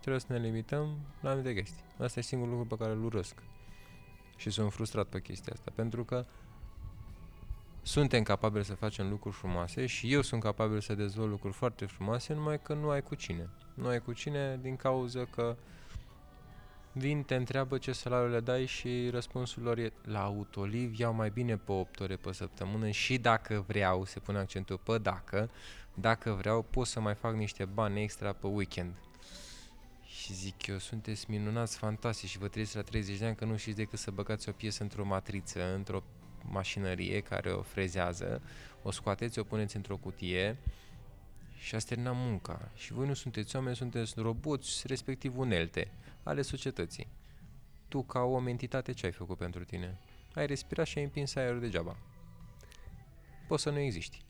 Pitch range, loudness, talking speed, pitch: 100-125 Hz, -36 LUFS, 180 wpm, 110 Hz